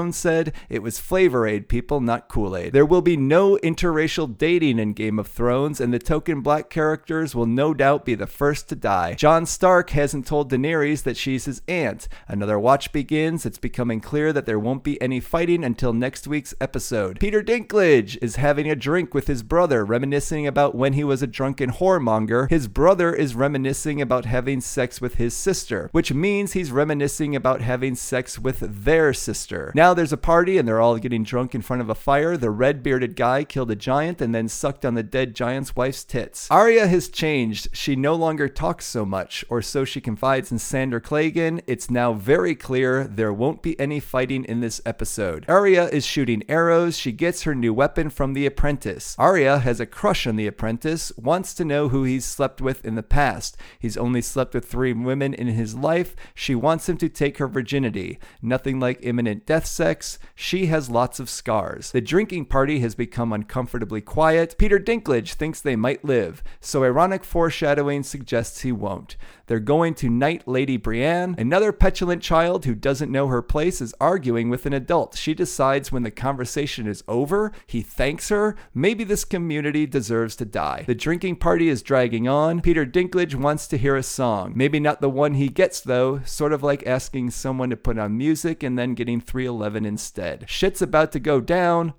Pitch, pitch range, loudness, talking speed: 140 Hz, 120-160 Hz, -22 LUFS, 195 wpm